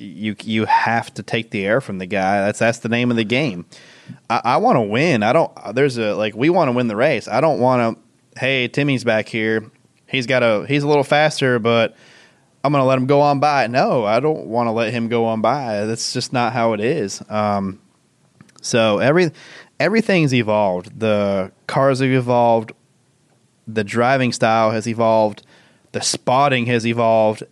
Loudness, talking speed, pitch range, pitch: -18 LUFS, 195 wpm, 110-135 Hz, 115 Hz